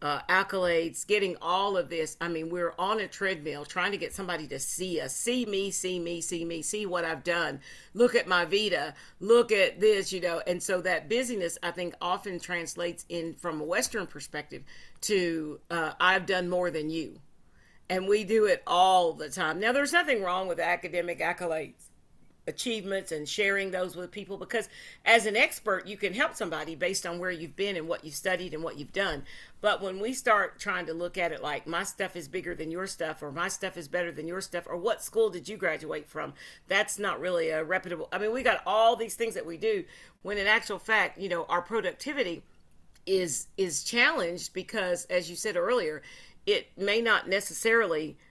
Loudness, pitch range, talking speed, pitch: -29 LUFS, 170-205 Hz, 205 wpm, 185 Hz